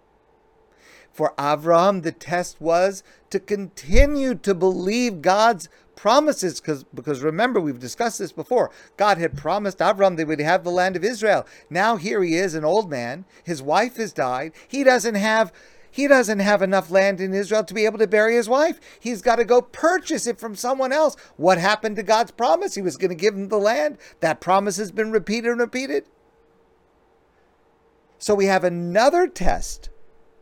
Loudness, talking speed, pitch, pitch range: -21 LUFS, 180 wpm, 215 Hz, 185-250 Hz